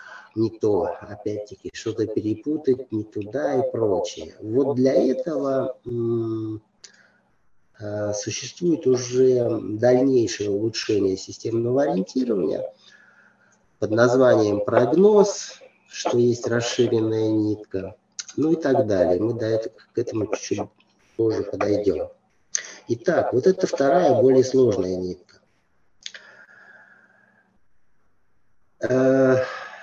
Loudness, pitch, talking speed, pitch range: -22 LUFS, 120 Hz, 95 wpm, 110-135 Hz